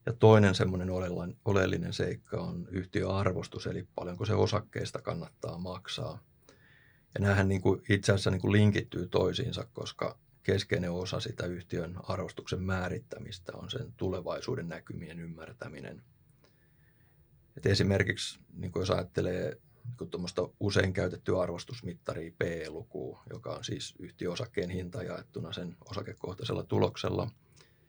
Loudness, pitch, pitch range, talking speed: -33 LUFS, 95 Hz, 90-105 Hz, 115 wpm